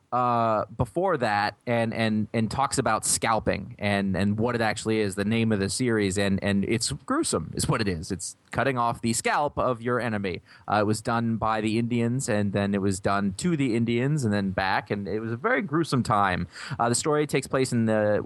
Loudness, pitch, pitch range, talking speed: -26 LUFS, 115 Hz, 105-125 Hz, 225 wpm